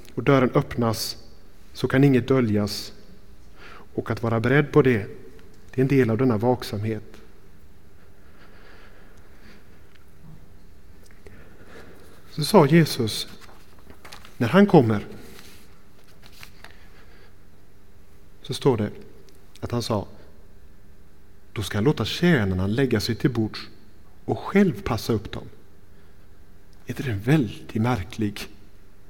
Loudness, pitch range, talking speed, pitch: -22 LUFS, 95-115 Hz, 105 wpm, 100 Hz